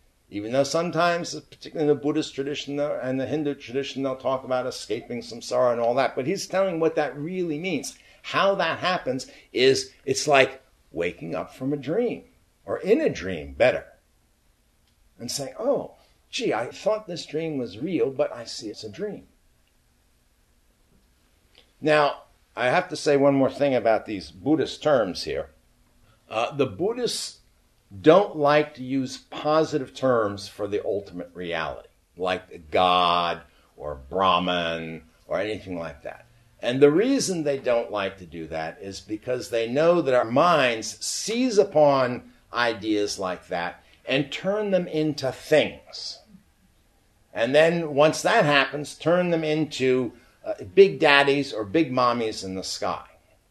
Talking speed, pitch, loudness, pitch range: 155 wpm, 135 Hz, -24 LUFS, 100-155 Hz